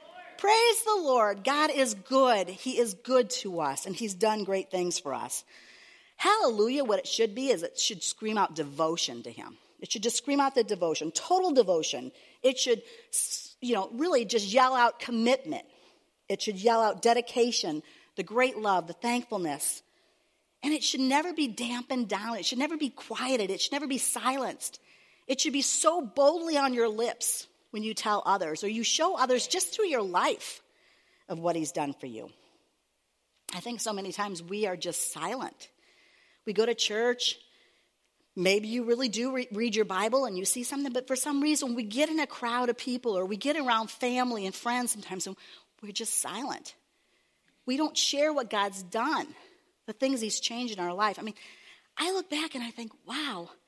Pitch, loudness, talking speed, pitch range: 245 Hz, -29 LUFS, 190 wpm, 215-285 Hz